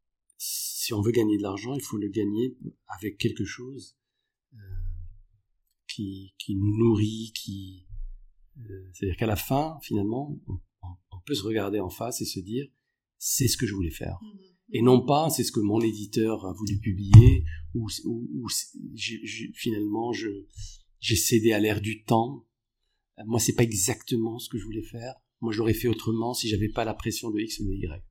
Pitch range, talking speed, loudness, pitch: 100-120 Hz, 180 wpm, -26 LUFS, 110 Hz